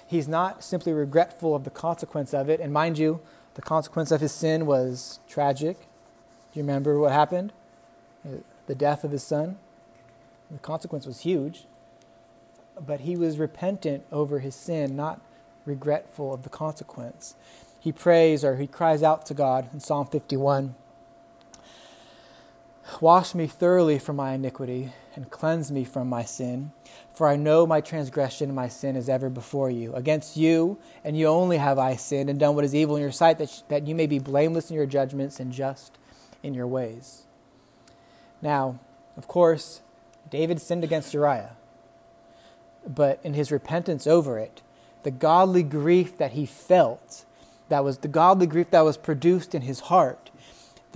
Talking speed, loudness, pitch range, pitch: 165 wpm, -25 LUFS, 135-160 Hz, 145 Hz